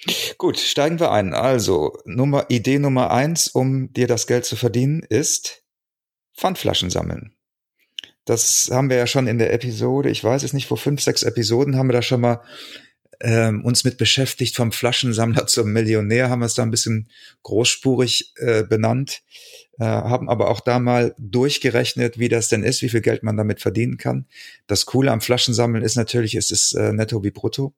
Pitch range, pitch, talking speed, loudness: 115-130 Hz, 120 Hz, 185 wpm, -19 LUFS